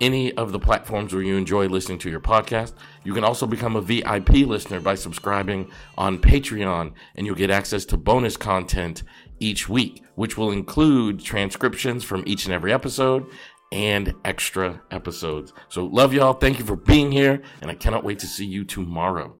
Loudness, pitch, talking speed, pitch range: -22 LUFS, 100 Hz, 180 wpm, 95-115 Hz